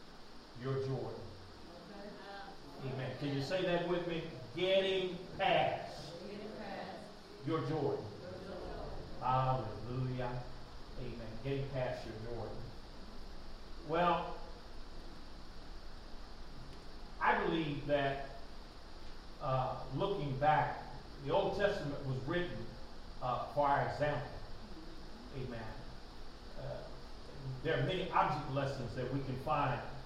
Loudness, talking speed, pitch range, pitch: -38 LUFS, 90 wpm, 125-165 Hz, 140 Hz